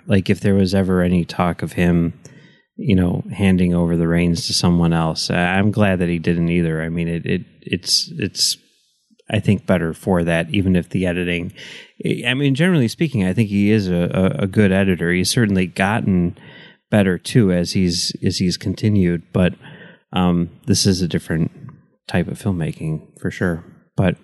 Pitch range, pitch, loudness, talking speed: 85-100 Hz, 90 Hz, -18 LUFS, 180 wpm